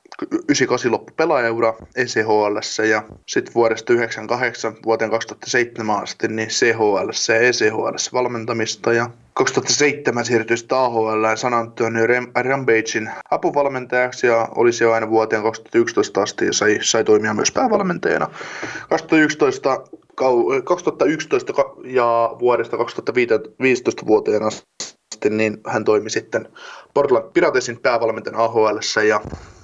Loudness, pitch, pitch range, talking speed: -19 LUFS, 115 Hz, 110-135 Hz, 105 wpm